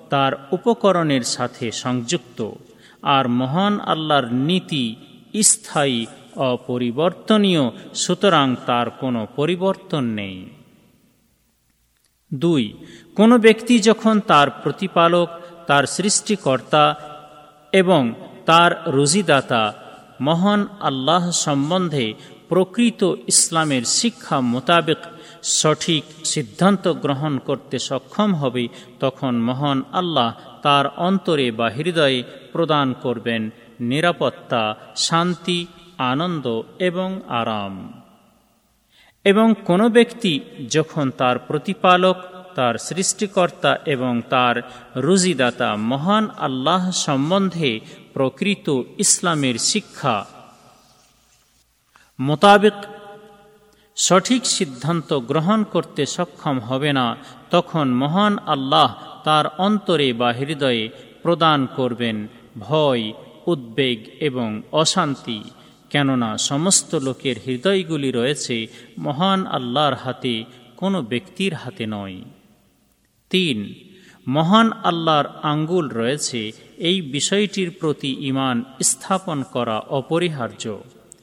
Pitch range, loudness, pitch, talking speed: 125-185 Hz, -19 LUFS, 150 Hz, 85 wpm